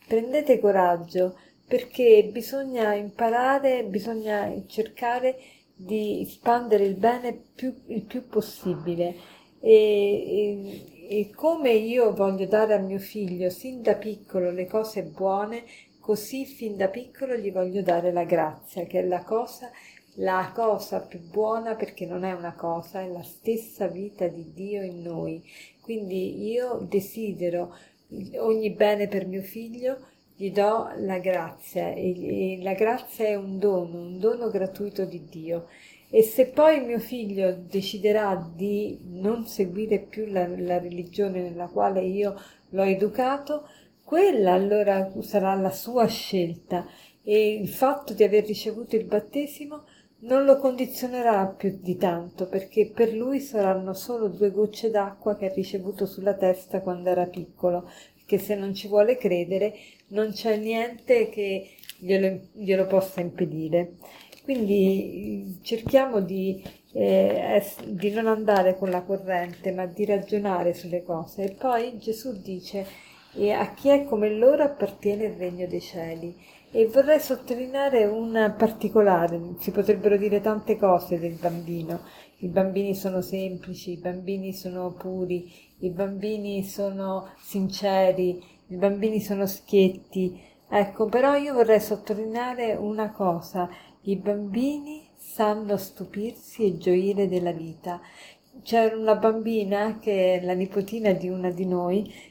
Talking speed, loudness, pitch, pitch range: 140 wpm, -25 LUFS, 200 Hz, 185-225 Hz